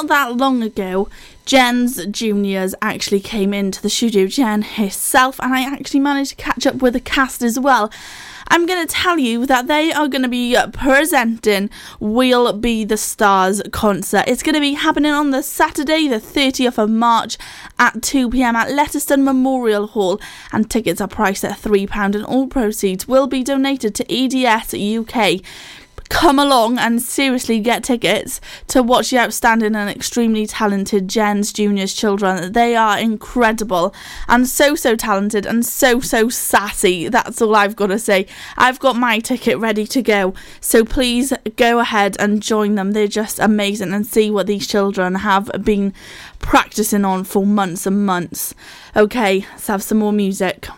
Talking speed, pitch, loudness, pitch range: 175 wpm, 225 Hz, -16 LUFS, 205-260 Hz